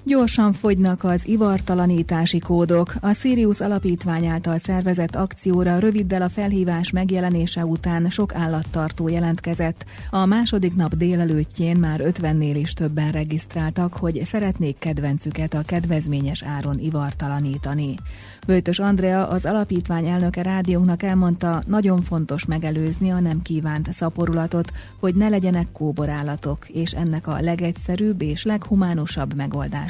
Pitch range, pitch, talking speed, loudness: 155-185 Hz, 170 Hz, 120 wpm, -21 LUFS